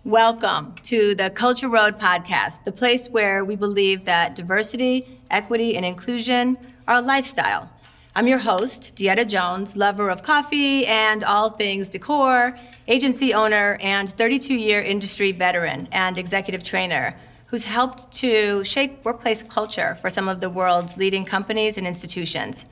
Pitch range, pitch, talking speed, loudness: 195-245 Hz, 215 Hz, 145 wpm, -20 LUFS